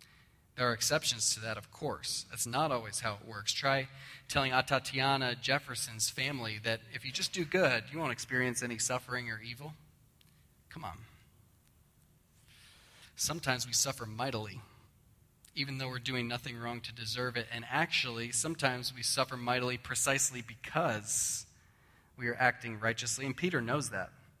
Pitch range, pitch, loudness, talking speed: 115-135 Hz, 125 Hz, -33 LUFS, 150 wpm